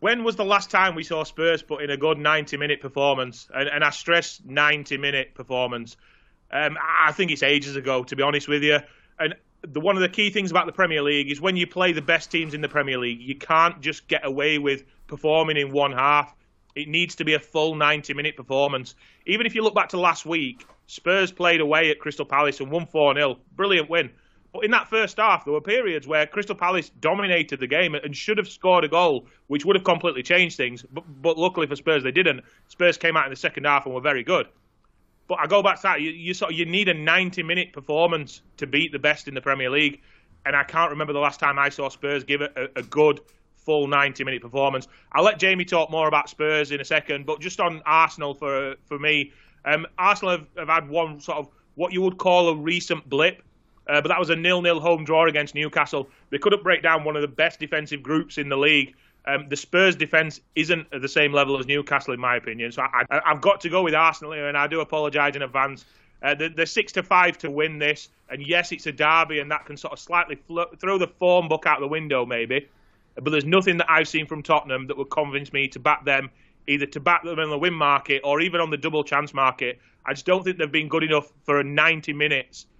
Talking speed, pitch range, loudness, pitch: 240 wpm, 140-170 Hz, -22 LUFS, 150 Hz